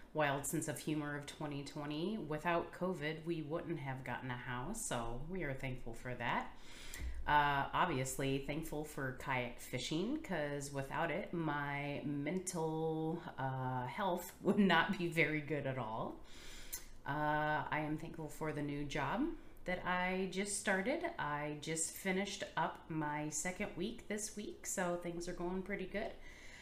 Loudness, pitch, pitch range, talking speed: -40 LUFS, 155 Hz, 145-180 Hz, 150 wpm